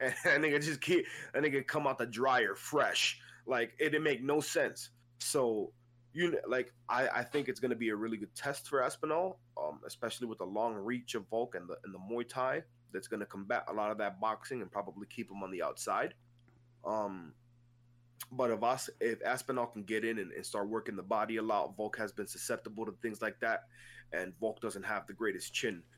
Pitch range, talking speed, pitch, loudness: 115-130 Hz, 220 wpm, 120 Hz, -36 LUFS